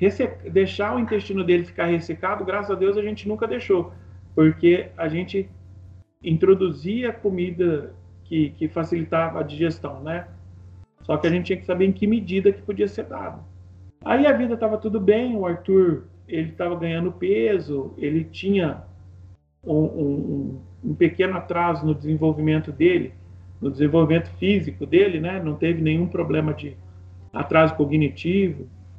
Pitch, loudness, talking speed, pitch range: 165 Hz, -22 LUFS, 150 wpm, 145-195 Hz